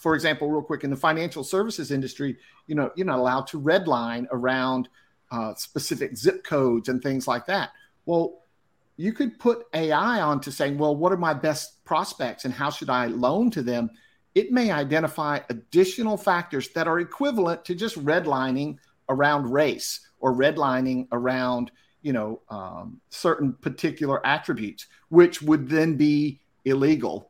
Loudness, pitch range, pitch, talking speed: -25 LUFS, 130-170 Hz, 150 Hz, 160 wpm